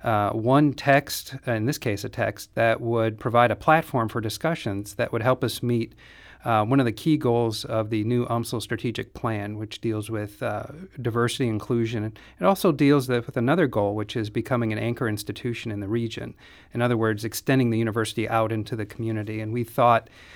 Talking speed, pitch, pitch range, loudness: 195 wpm, 115 Hz, 110-125 Hz, -25 LUFS